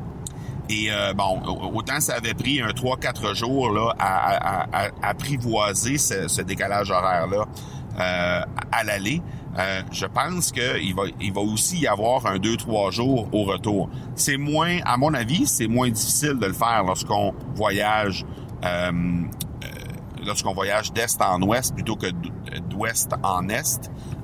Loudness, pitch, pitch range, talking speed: -23 LUFS, 115 Hz, 100-135 Hz, 150 wpm